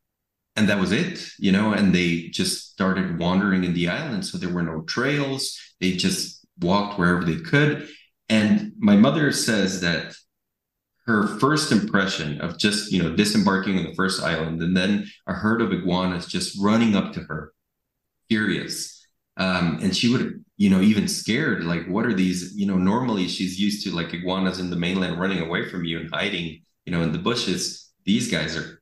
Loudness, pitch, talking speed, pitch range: -23 LUFS, 95 Hz, 190 wpm, 85-110 Hz